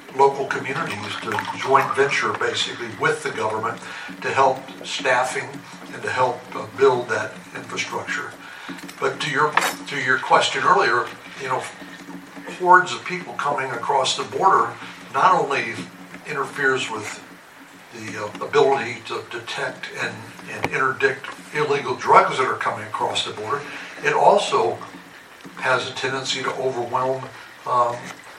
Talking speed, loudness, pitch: 130 wpm, -21 LUFS, 140 Hz